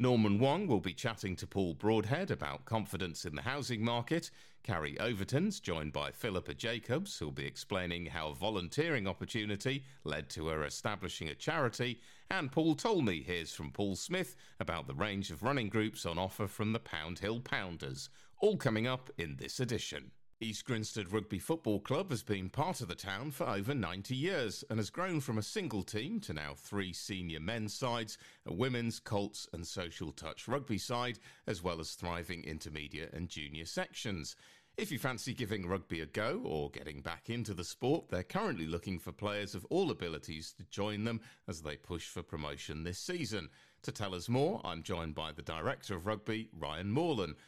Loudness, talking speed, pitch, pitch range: -38 LUFS, 185 wpm, 105 Hz, 85-120 Hz